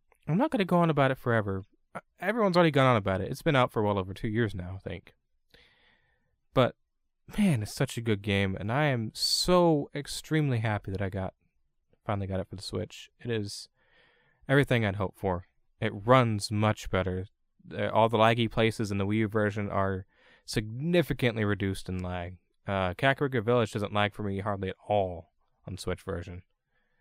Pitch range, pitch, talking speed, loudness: 95-125 Hz, 105 Hz, 190 wpm, -29 LUFS